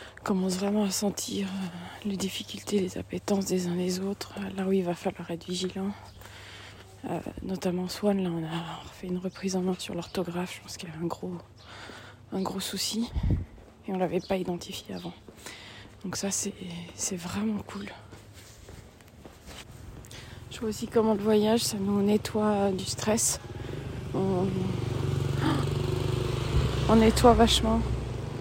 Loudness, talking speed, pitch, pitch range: -29 LUFS, 155 wpm, 180 Hz, 125-195 Hz